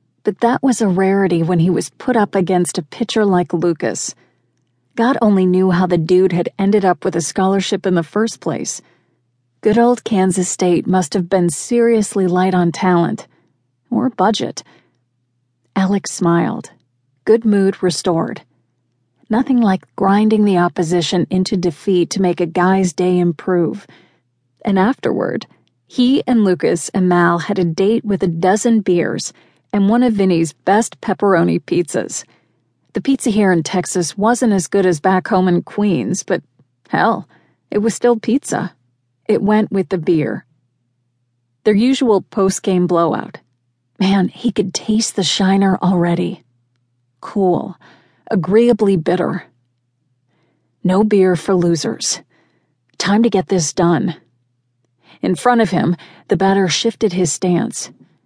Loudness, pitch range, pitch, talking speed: -16 LUFS, 170-205 Hz, 185 Hz, 145 wpm